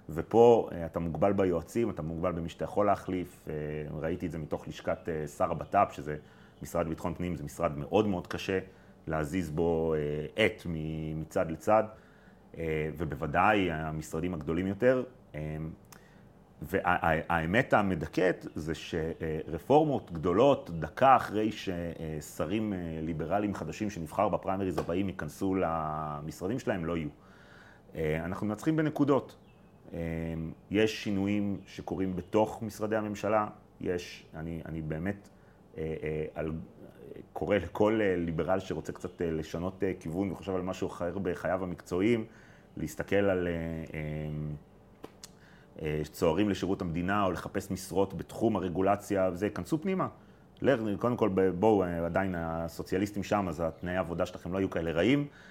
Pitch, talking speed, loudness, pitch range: 90 Hz, 115 wpm, -31 LUFS, 80-100 Hz